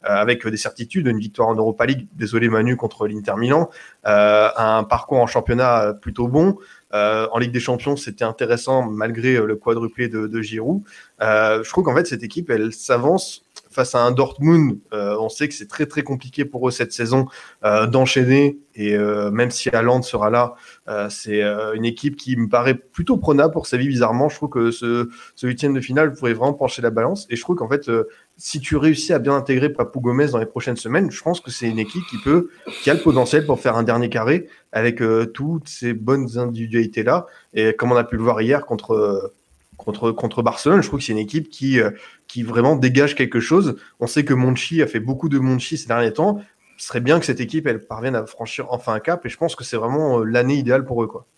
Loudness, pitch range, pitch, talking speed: -19 LUFS, 115-145 Hz, 125 Hz, 230 wpm